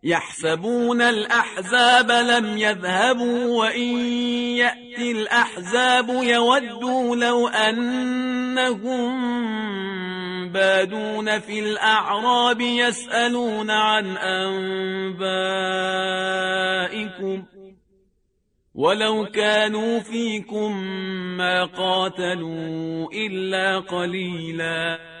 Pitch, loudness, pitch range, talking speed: 215 Hz, -21 LUFS, 190-240 Hz, 55 wpm